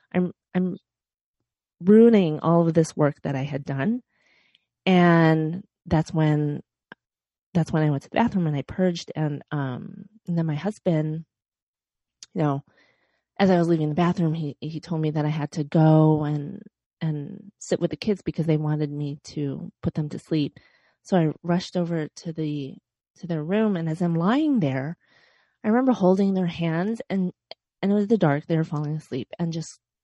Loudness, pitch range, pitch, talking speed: -24 LUFS, 150-185 Hz, 165 Hz, 185 wpm